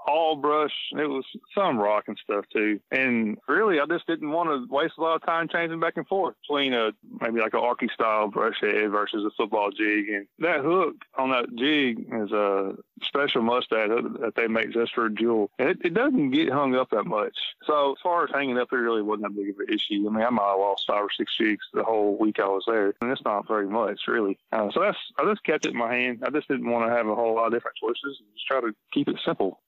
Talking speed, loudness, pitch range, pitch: 255 wpm, -25 LUFS, 110-160 Hz, 125 Hz